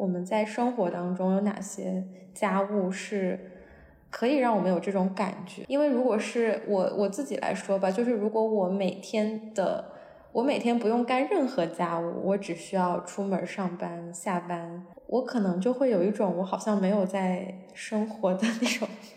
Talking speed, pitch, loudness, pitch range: 255 characters per minute, 200 Hz, -28 LUFS, 185-230 Hz